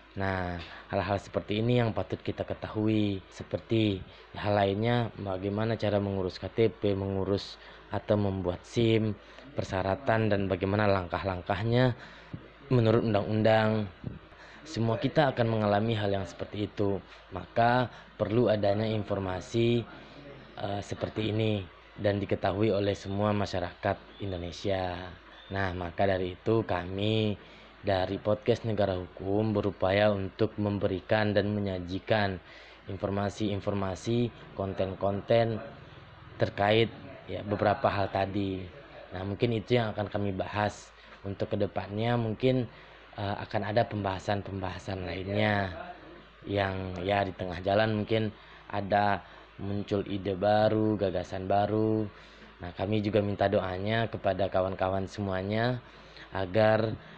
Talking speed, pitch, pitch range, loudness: 110 wpm, 100 Hz, 95-110 Hz, -30 LUFS